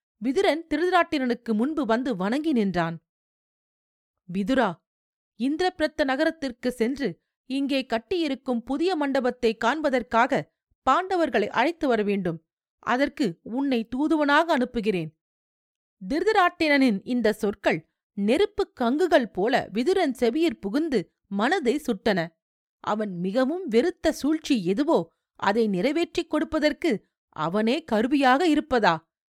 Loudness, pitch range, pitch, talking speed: -25 LUFS, 215-305 Hz, 255 Hz, 90 wpm